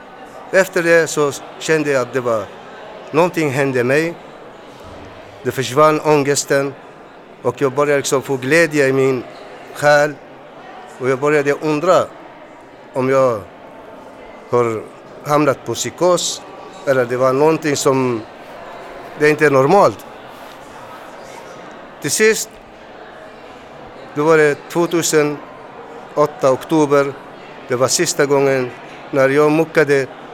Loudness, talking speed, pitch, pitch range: -16 LUFS, 110 wpm, 145 Hz, 135-155 Hz